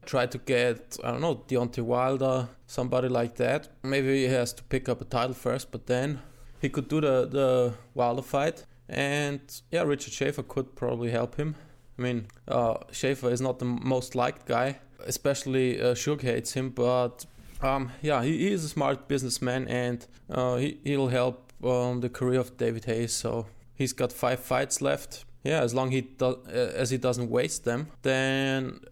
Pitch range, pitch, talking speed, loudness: 125-135 Hz, 125 Hz, 185 wpm, -29 LUFS